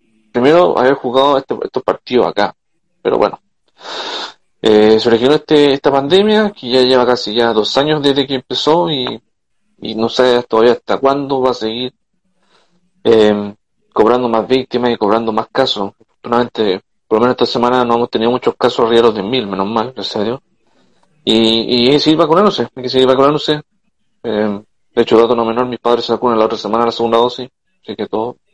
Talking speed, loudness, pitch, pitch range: 190 wpm, -13 LUFS, 125 Hz, 115-135 Hz